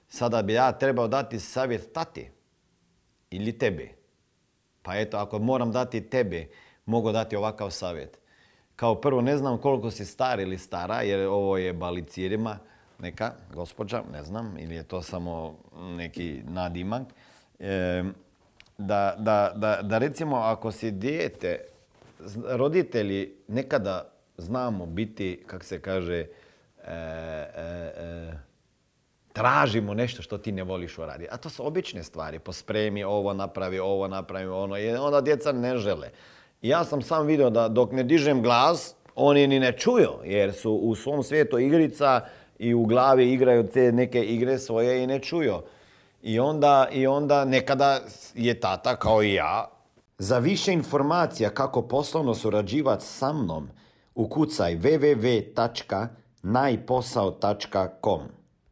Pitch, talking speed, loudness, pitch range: 115 Hz, 140 wpm, -26 LUFS, 95-130 Hz